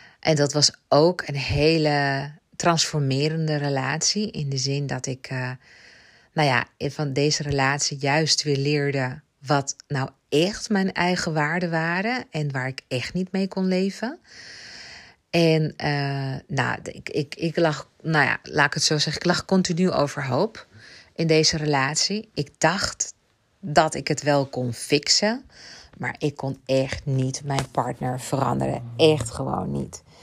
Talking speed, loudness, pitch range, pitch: 155 wpm, -23 LUFS, 135-160 Hz, 145 Hz